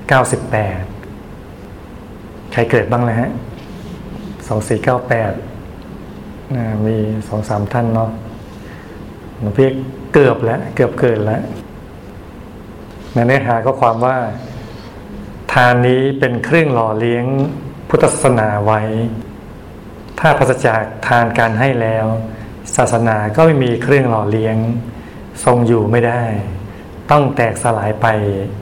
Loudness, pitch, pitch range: -15 LUFS, 115 Hz, 105-125 Hz